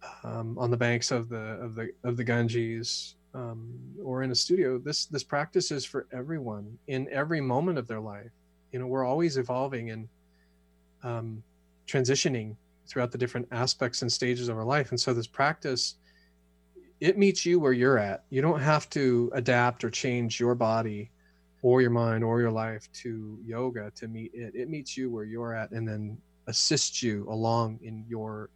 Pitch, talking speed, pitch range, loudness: 120 Hz, 185 wpm, 110-130 Hz, -29 LUFS